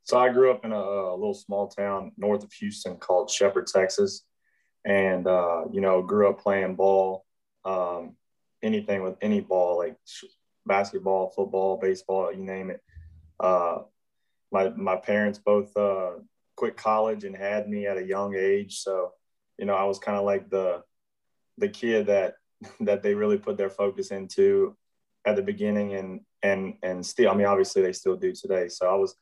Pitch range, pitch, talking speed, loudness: 95-110 Hz, 100 Hz, 180 wpm, -26 LUFS